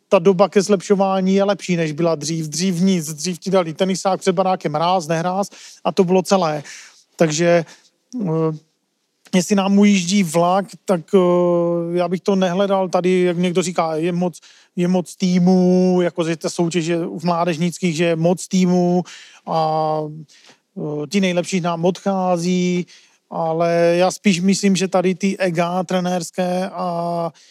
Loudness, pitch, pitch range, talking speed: -18 LUFS, 180 Hz, 170-190 Hz, 150 wpm